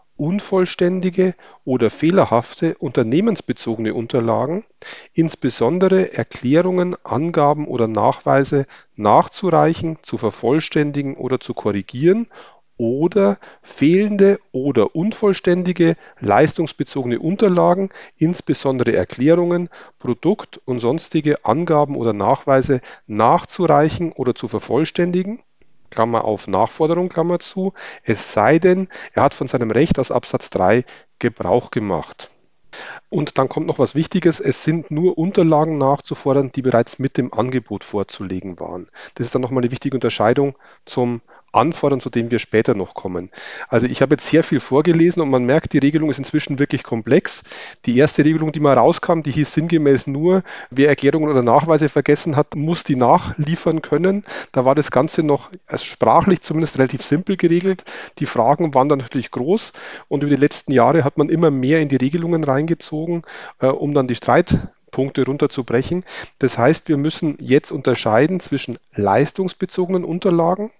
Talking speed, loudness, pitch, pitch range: 140 wpm, -18 LUFS, 150 Hz, 130-170 Hz